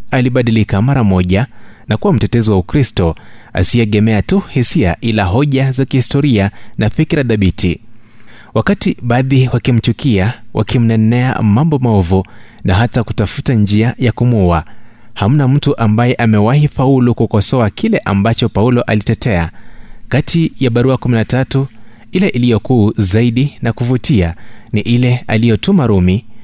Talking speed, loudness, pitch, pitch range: 120 wpm, -13 LUFS, 115 Hz, 105-130 Hz